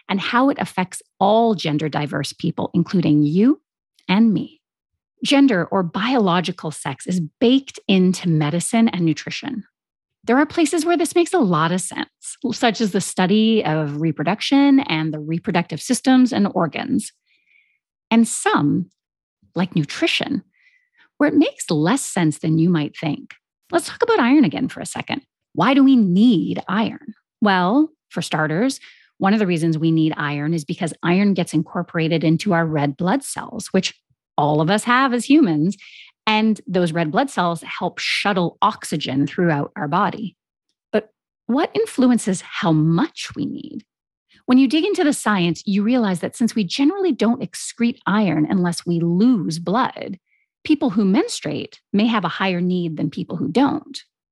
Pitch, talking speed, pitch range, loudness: 195 Hz, 160 wpm, 170-255 Hz, -19 LUFS